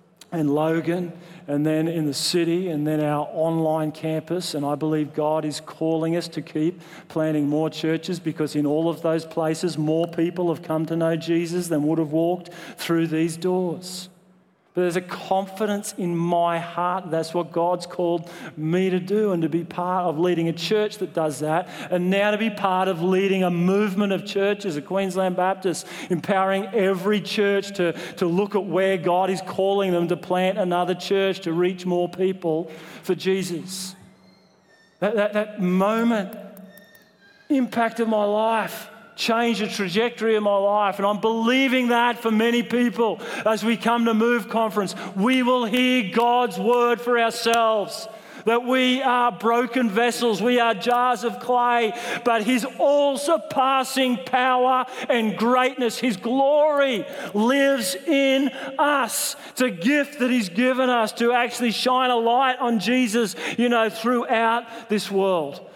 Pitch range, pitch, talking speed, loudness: 175-235 Hz, 200 Hz, 165 wpm, -22 LUFS